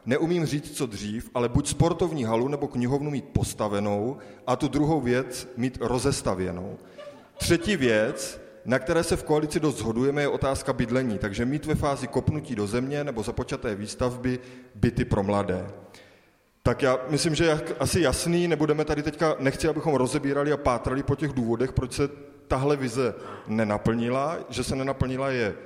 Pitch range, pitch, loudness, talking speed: 120-150 Hz, 130 Hz, -26 LUFS, 160 wpm